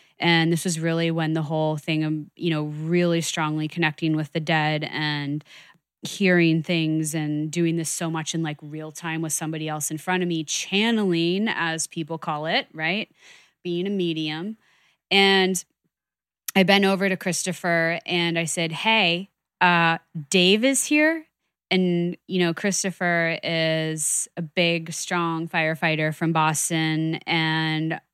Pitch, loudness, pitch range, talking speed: 165 Hz, -23 LUFS, 160-180 Hz, 150 wpm